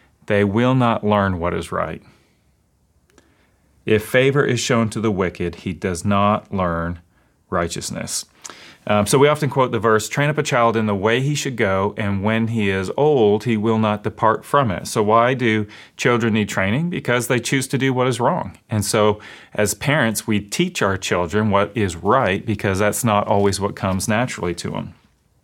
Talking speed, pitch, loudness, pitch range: 190 wpm, 110 Hz, -19 LUFS, 100-120 Hz